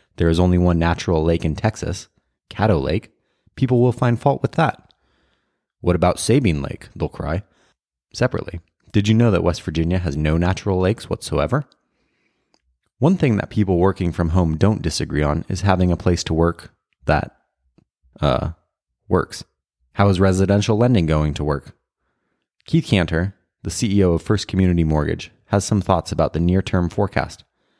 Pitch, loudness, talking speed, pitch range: 90 Hz, -20 LUFS, 160 wpm, 80-105 Hz